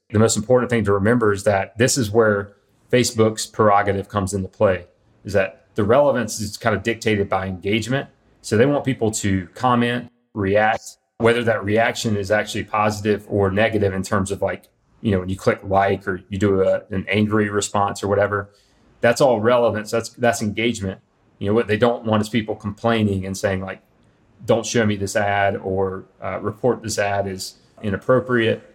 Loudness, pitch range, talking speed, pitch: -20 LUFS, 100-115 Hz, 190 wpm, 105 Hz